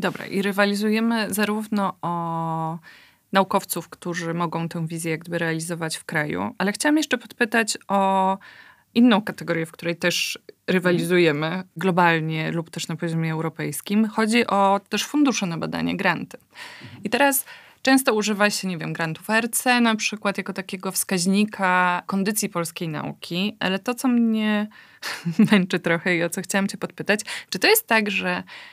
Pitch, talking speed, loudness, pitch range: 195 Hz, 150 wpm, -22 LUFS, 170-215 Hz